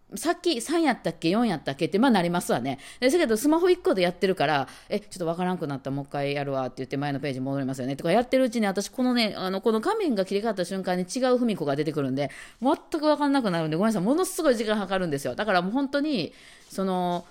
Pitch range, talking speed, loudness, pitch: 165-255 Hz, 540 characters per minute, -26 LUFS, 195 Hz